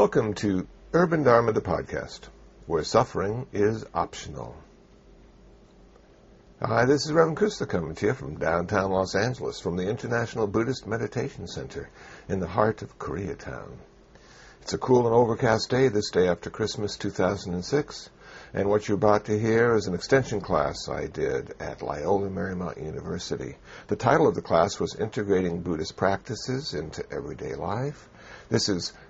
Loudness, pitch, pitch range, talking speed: -26 LUFS, 105 Hz, 95-120 Hz, 155 wpm